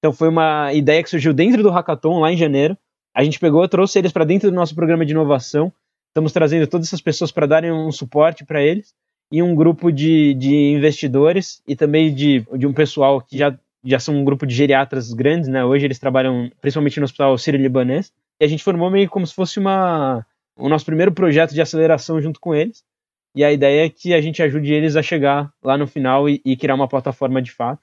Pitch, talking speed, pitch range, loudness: 155 Hz, 225 wpm, 140-165 Hz, -17 LUFS